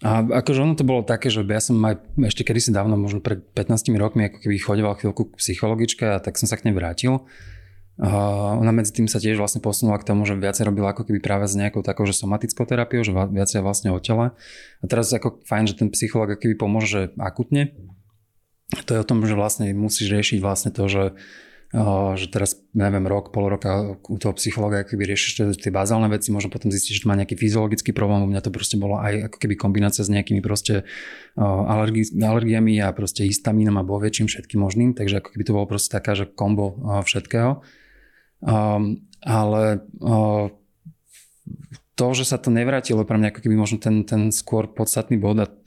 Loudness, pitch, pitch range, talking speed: -21 LUFS, 105 Hz, 100-115 Hz, 205 wpm